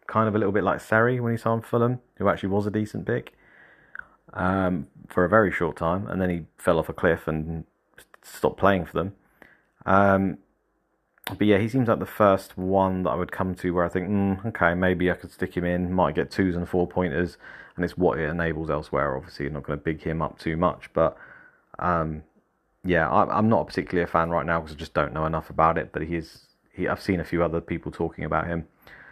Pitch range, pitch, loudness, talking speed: 80-95 Hz, 90 Hz, -25 LUFS, 235 wpm